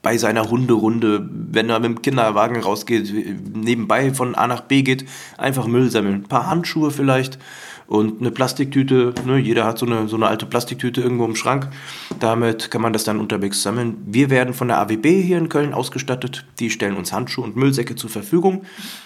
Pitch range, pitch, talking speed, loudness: 110-130 Hz, 120 Hz, 190 wpm, -19 LUFS